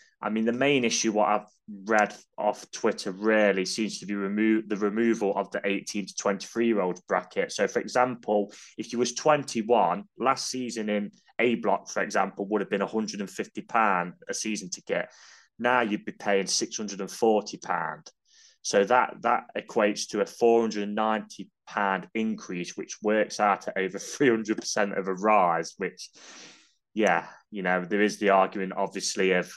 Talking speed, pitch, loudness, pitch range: 190 wpm, 105 Hz, -27 LUFS, 100-110 Hz